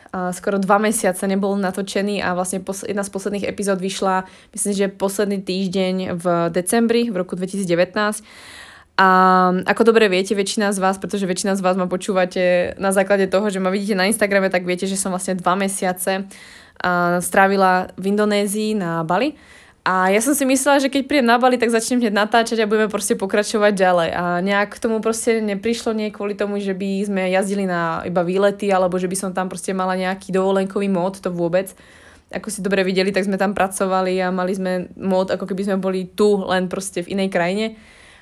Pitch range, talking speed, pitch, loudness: 185-205 Hz, 195 wpm, 195 Hz, -19 LUFS